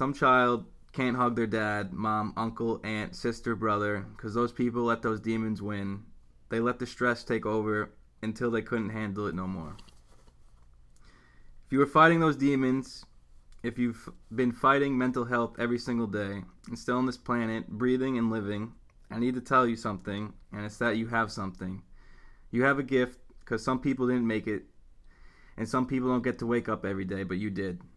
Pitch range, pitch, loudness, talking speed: 100-125 Hz, 115 Hz, -29 LUFS, 190 wpm